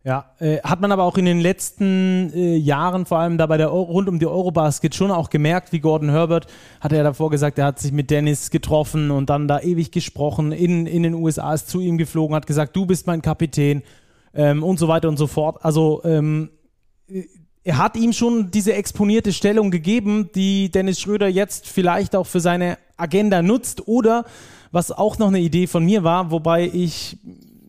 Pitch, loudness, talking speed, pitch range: 170 Hz, -19 LUFS, 200 wpm, 155-190 Hz